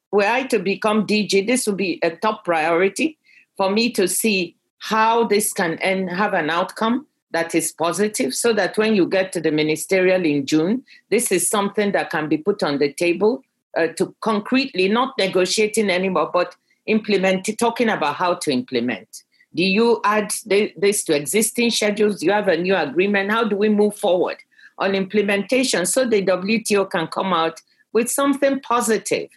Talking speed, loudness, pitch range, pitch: 180 wpm, -19 LUFS, 180-225 Hz, 205 Hz